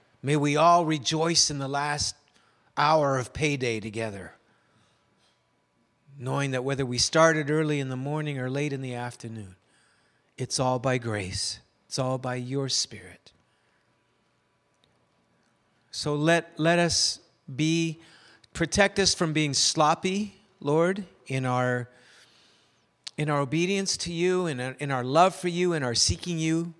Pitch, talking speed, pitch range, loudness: 145 Hz, 140 wpm, 125-165 Hz, -26 LUFS